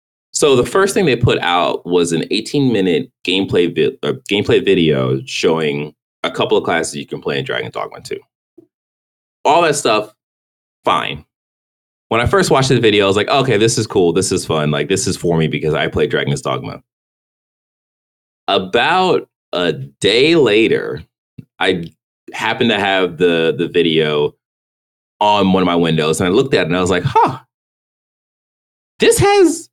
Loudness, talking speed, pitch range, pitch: -15 LUFS, 175 wpm, 70-95 Hz, 80 Hz